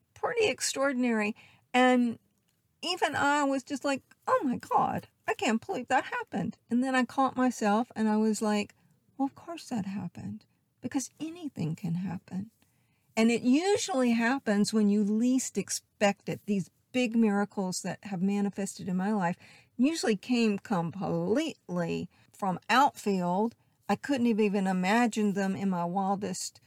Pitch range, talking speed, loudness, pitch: 195-255 Hz, 150 wpm, -29 LUFS, 220 Hz